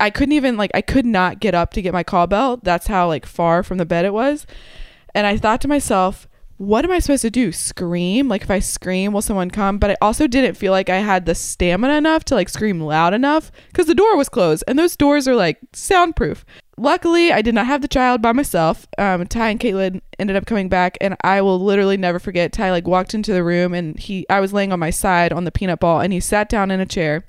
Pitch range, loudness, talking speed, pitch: 180-250 Hz, -17 LUFS, 255 wpm, 195 Hz